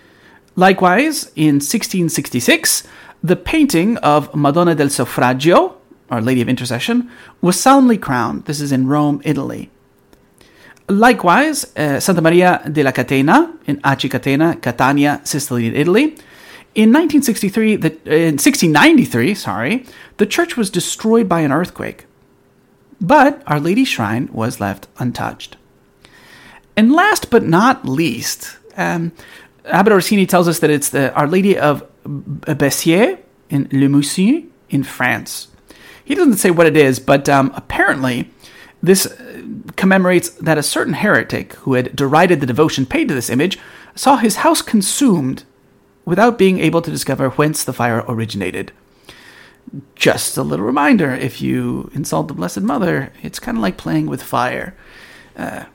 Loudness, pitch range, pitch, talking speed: -15 LUFS, 140-215 Hz, 165 Hz, 140 wpm